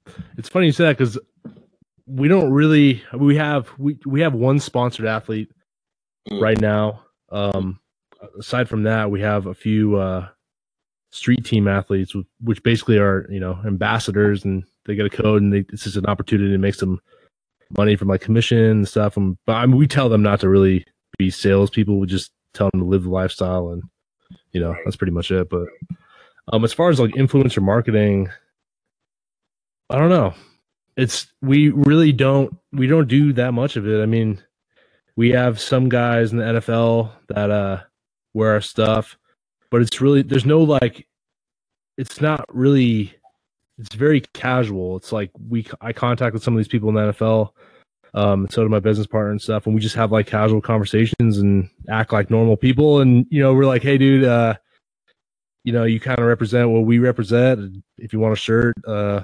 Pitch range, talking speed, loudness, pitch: 100-125 Hz, 195 wpm, -18 LUFS, 110 Hz